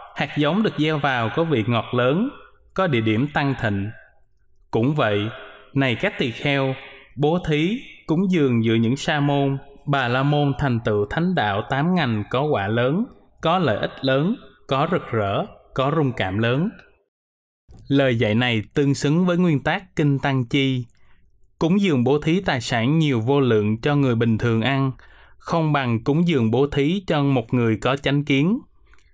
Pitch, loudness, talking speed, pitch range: 140 Hz, -21 LUFS, 180 wpm, 115-155 Hz